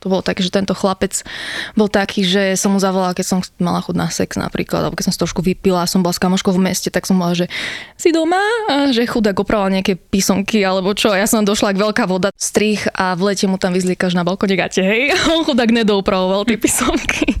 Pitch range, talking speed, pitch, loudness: 185-215 Hz, 235 wpm, 195 Hz, -16 LUFS